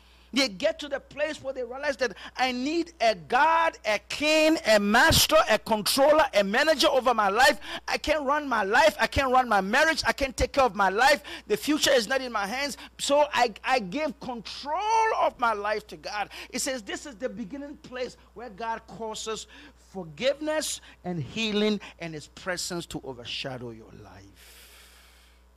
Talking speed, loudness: 185 wpm, -25 LUFS